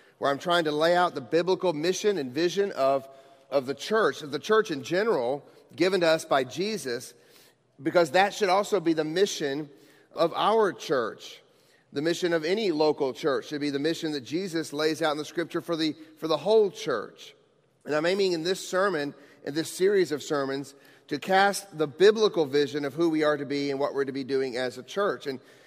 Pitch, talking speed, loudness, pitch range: 160 Hz, 210 wpm, -27 LUFS, 145-190 Hz